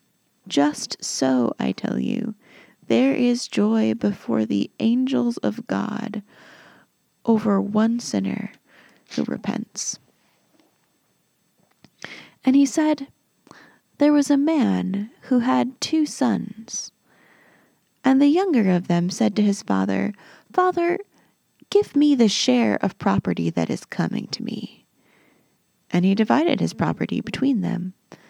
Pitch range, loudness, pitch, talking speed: 175-270 Hz, -22 LUFS, 220 Hz, 120 wpm